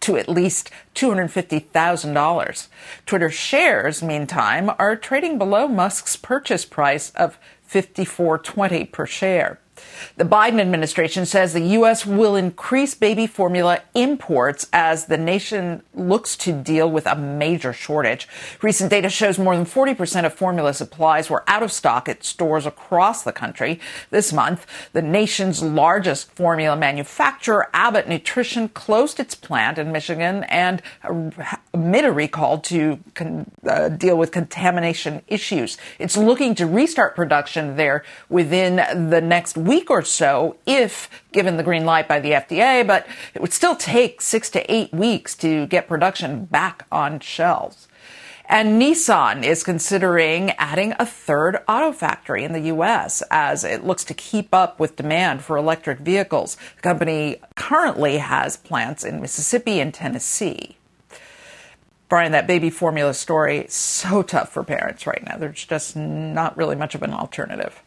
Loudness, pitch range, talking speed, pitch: -19 LUFS, 160-205 Hz, 150 wpm, 175 Hz